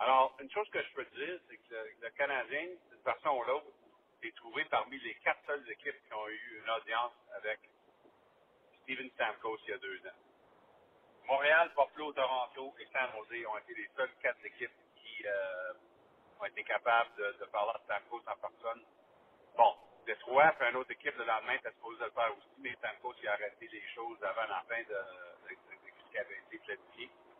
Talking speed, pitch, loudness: 195 wpm, 285 Hz, -36 LUFS